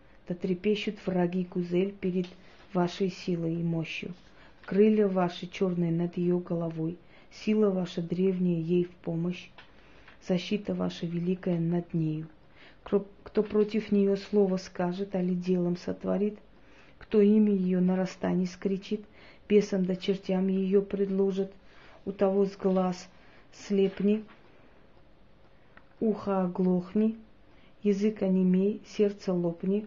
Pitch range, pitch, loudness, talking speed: 180-200 Hz, 185 Hz, -29 LUFS, 115 wpm